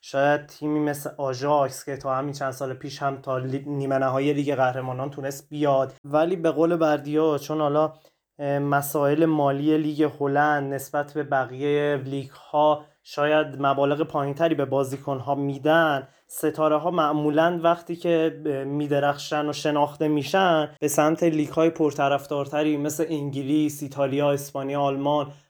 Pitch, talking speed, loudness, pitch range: 145 Hz, 140 wpm, -24 LUFS, 140-155 Hz